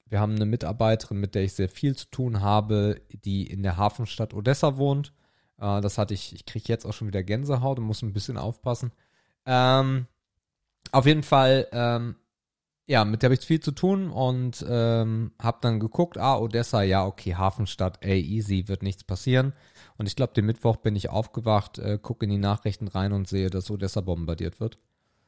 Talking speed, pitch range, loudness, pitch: 195 wpm, 100-125 Hz, -26 LUFS, 110 Hz